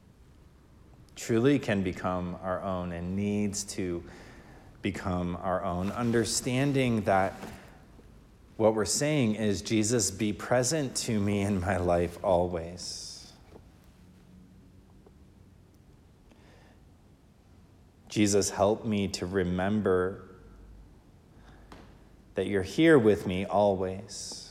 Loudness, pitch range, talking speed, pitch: -28 LUFS, 90-105 Hz, 90 wpm, 95 Hz